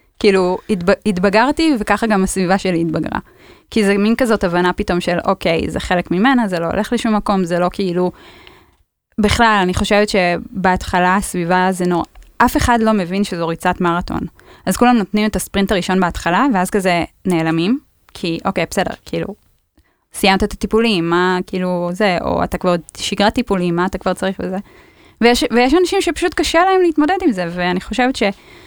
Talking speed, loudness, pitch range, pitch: 170 wpm, -16 LUFS, 180-225 Hz, 195 Hz